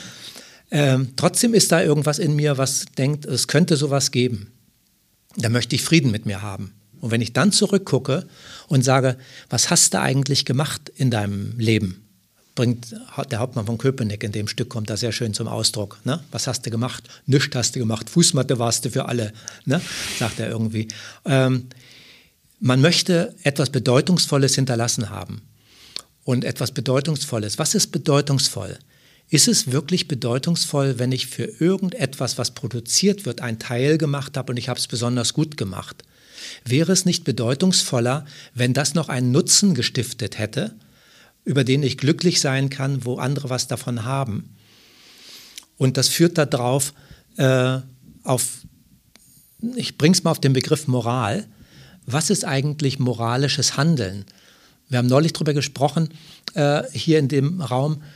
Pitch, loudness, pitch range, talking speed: 135 Hz, -20 LUFS, 120-150 Hz, 160 wpm